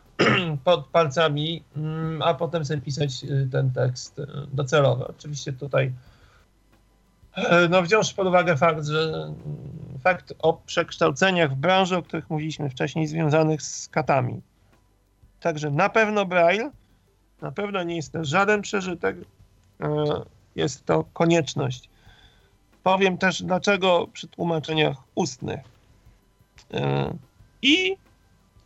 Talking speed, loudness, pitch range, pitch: 105 wpm, -23 LUFS, 125-175 Hz, 155 Hz